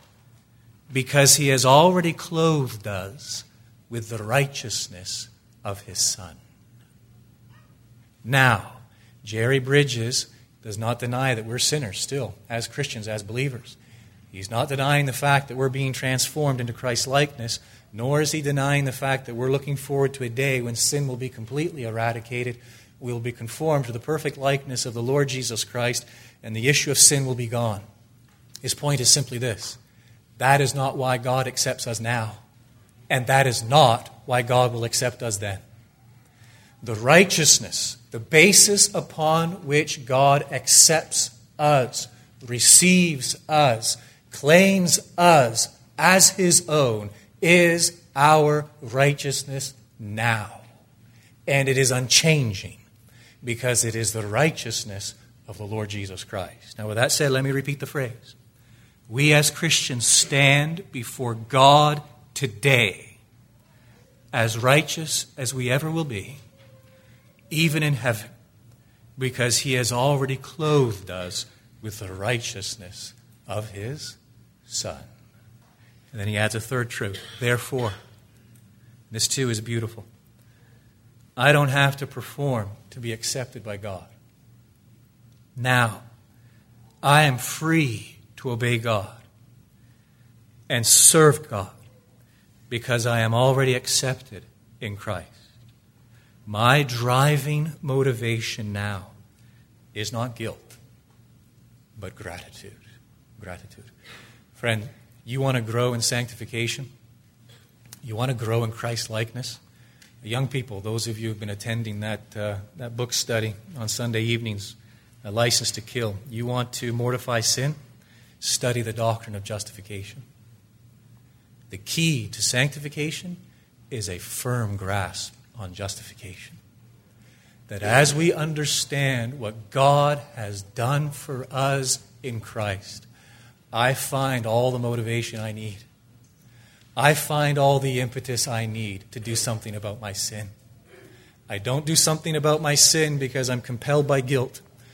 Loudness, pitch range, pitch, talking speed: -22 LUFS, 115-135 Hz, 120 Hz, 130 wpm